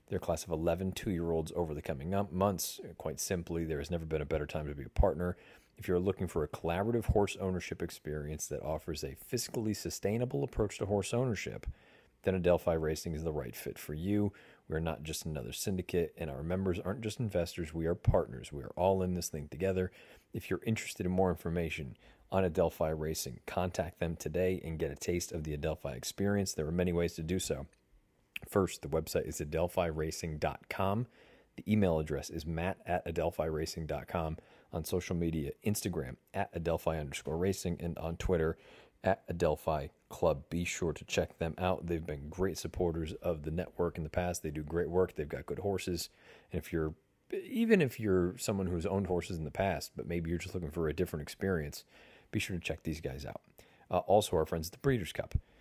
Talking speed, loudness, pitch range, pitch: 200 wpm, -35 LUFS, 80-95 Hz, 85 Hz